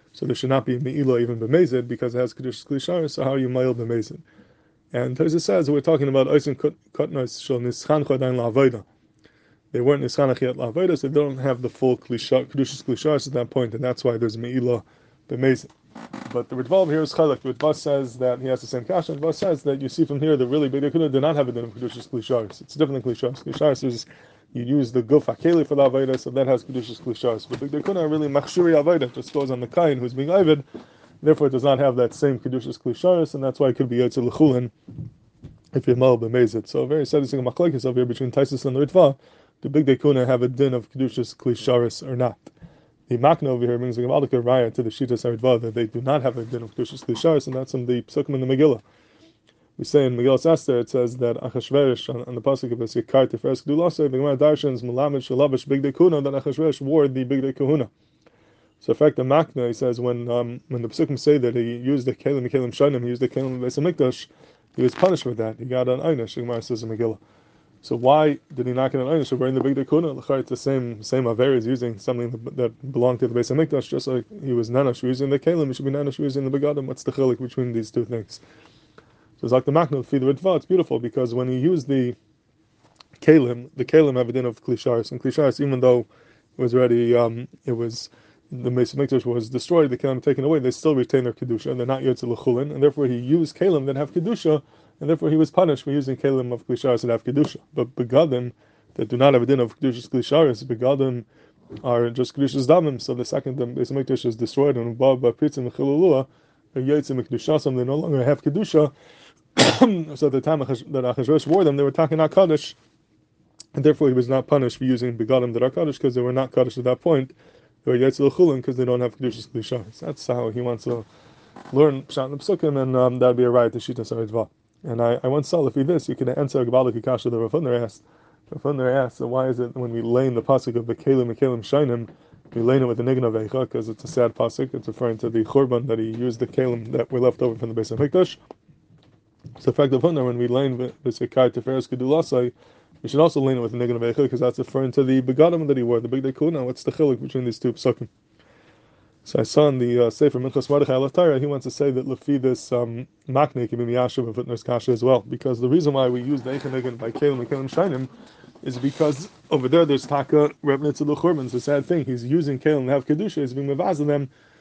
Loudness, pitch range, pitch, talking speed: -22 LUFS, 125-145 Hz, 130 Hz, 230 wpm